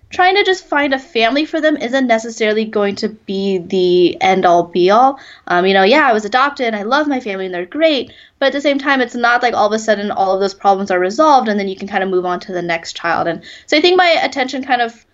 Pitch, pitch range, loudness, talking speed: 225 Hz, 195-275 Hz, -14 LUFS, 280 wpm